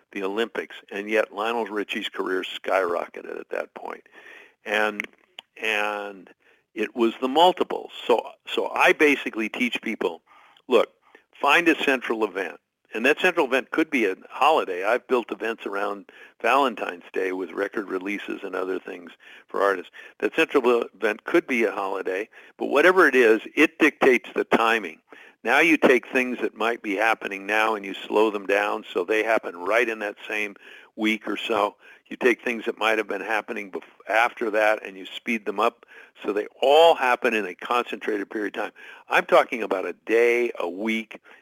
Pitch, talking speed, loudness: 120 Hz, 175 wpm, -23 LUFS